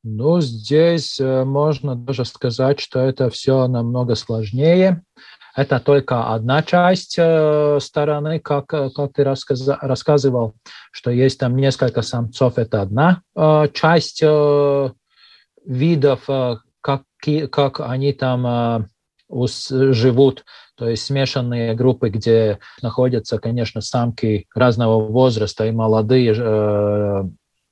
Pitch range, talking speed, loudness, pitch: 115-145 Hz, 115 wpm, -18 LUFS, 130 Hz